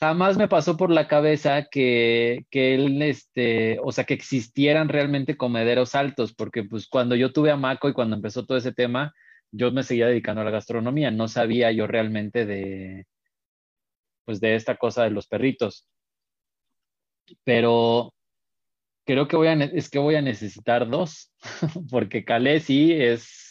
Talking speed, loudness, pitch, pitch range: 165 wpm, -23 LUFS, 125 Hz, 115-145 Hz